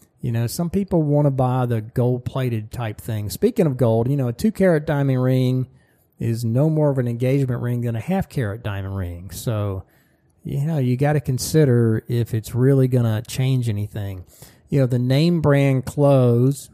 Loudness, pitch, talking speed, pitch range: -20 LUFS, 125 Hz, 195 wpm, 115-140 Hz